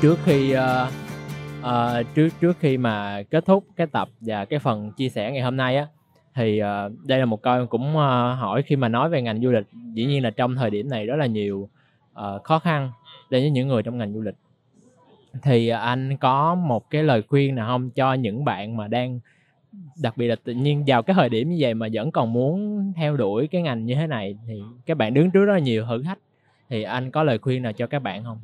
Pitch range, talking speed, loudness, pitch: 115-145 Hz, 240 wpm, -23 LUFS, 125 Hz